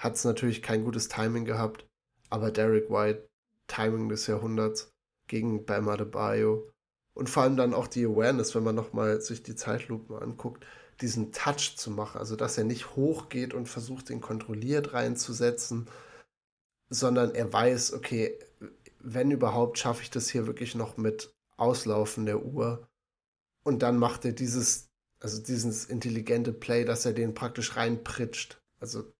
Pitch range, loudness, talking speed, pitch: 110-120 Hz, -30 LUFS, 155 wpm, 115 Hz